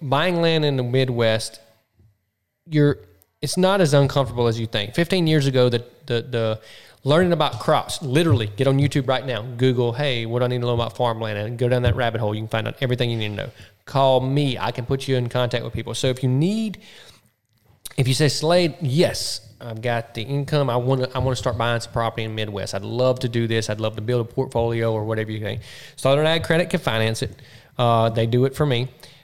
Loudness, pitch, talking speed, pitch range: -21 LUFS, 125 Hz, 240 wpm, 115-135 Hz